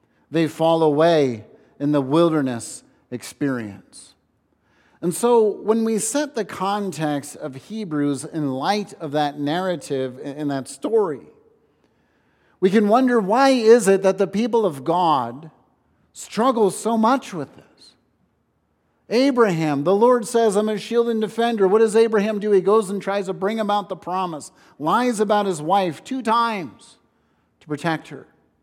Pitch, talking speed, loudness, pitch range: 190 Hz, 150 wpm, -20 LUFS, 150-220 Hz